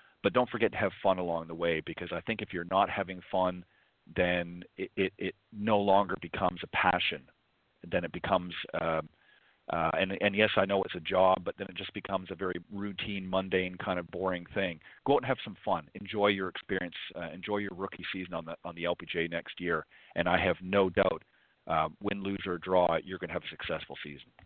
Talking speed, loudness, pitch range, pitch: 220 wpm, -32 LUFS, 85-100 Hz, 95 Hz